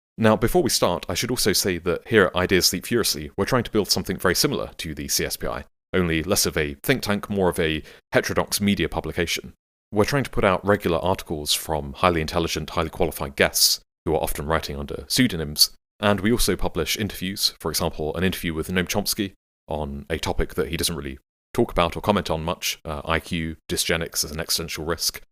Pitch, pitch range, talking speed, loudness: 85 Hz, 80-100 Hz, 205 wpm, -23 LUFS